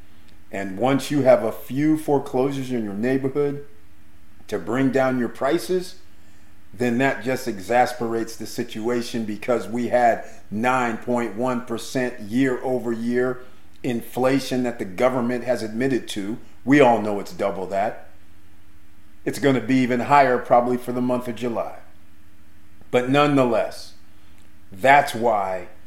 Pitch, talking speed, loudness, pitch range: 120 Hz, 130 wpm, -22 LUFS, 100-130 Hz